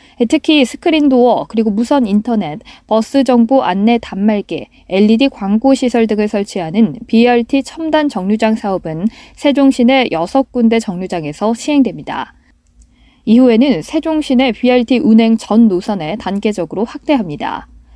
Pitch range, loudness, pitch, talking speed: 205-260 Hz, -13 LUFS, 230 Hz, 305 characters per minute